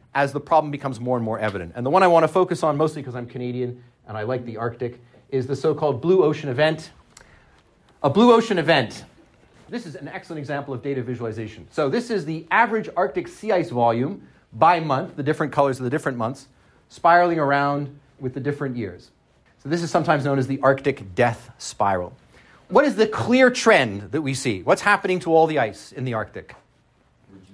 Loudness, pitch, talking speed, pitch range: -21 LUFS, 140 Hz, 205 wpm, 120-160 Hz